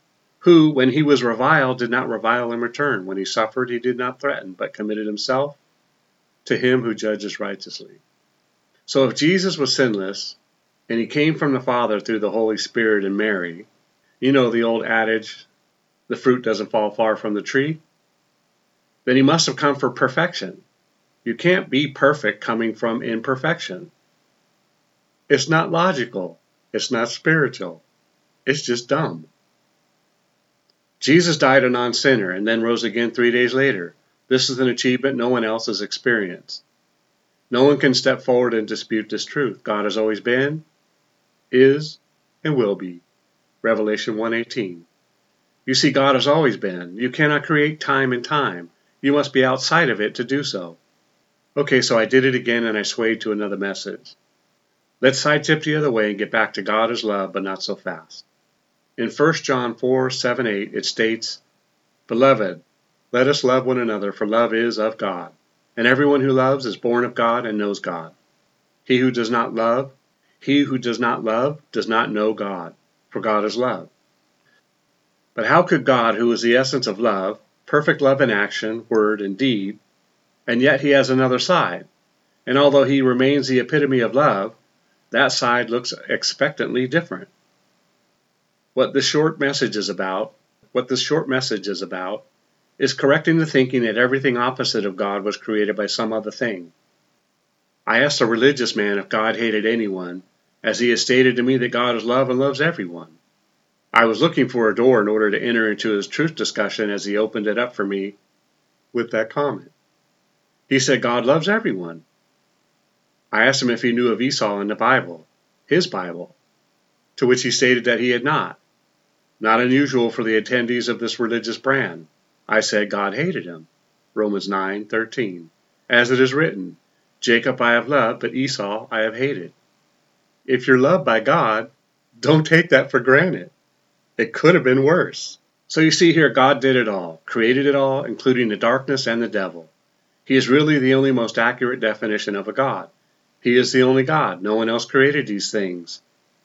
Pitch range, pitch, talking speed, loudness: 110-135 Hz, 120 Hz, 175 wpm, -19 LUFS